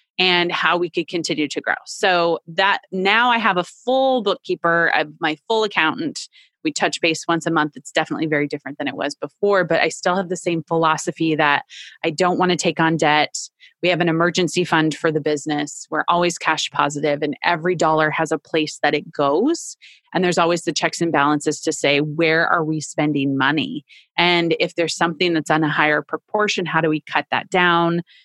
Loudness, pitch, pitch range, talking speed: -19 LUFS, 170 Hz, 155-180 Hz, 210 wpm